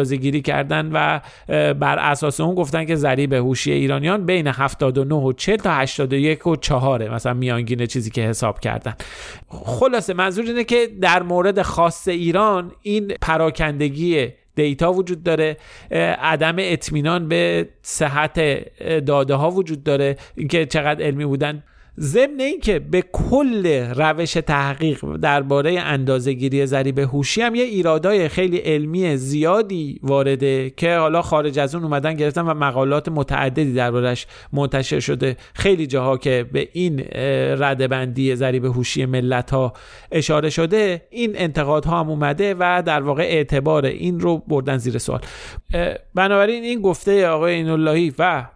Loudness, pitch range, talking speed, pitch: -19 LUFS, 135-175 Hz, 140 wpm, 150 Hz